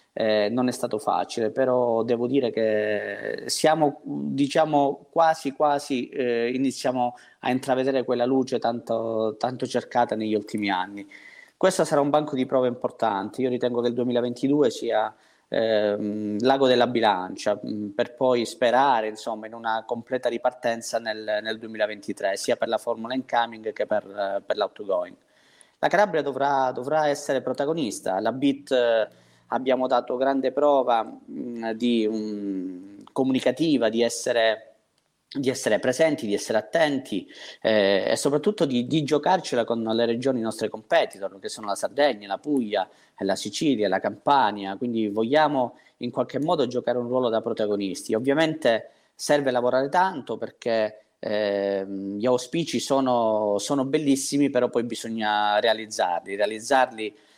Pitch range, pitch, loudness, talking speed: 110-135 Hz, 120 Hz, -24 LUFS, 140 wpm